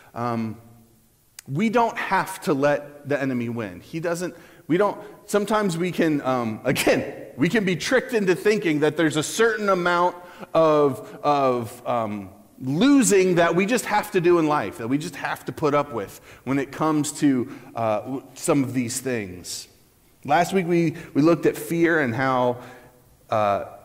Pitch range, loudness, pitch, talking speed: 125-175 Hz, -22 LUFS, 145 Hz, 170 wpm